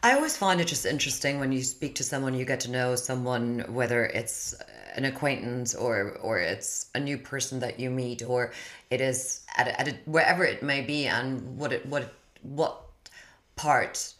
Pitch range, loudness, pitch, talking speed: 125-140 Hz, -28 LUFS, 130 Hz, 195 wpm